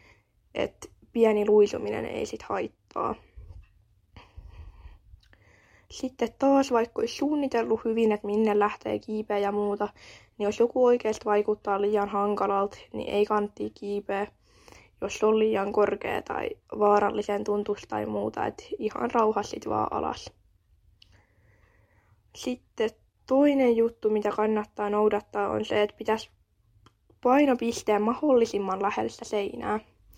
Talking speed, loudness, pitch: 115 wpm, -27 LUFS, 205 Hz